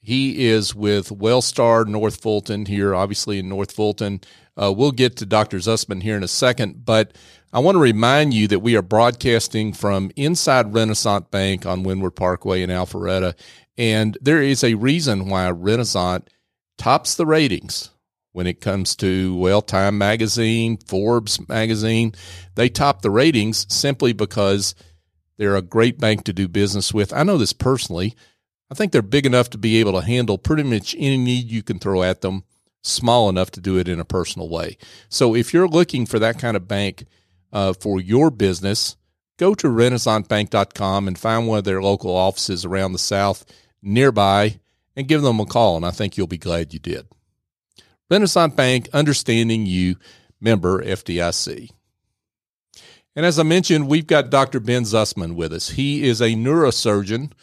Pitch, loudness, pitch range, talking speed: 105 Hz, -19 LUFS, 95-120 Hz, 175 wpm